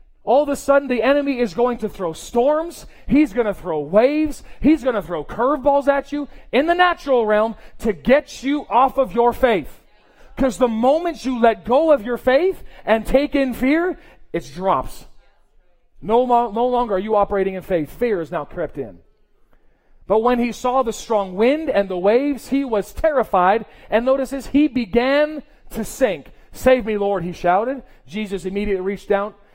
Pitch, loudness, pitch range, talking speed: 245 Hz, -19 LUFS, 205-275 Hz, 185 wpm